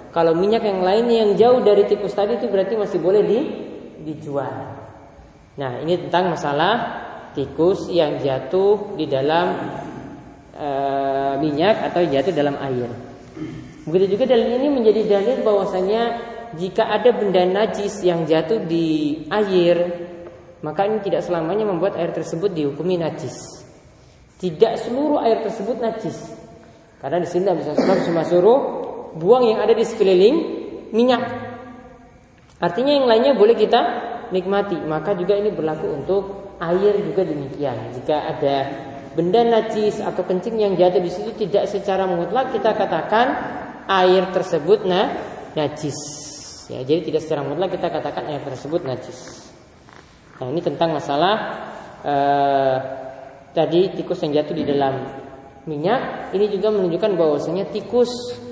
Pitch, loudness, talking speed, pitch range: 180 Hz, -20 LUFS, 135 wpm, 150-215 Hz